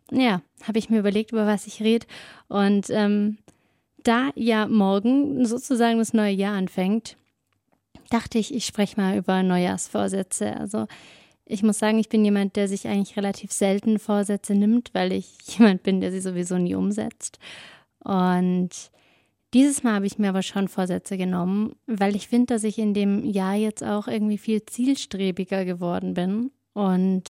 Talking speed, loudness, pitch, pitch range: 165 wpm, -23 LUFS, 205 Hz, 190-220 Hz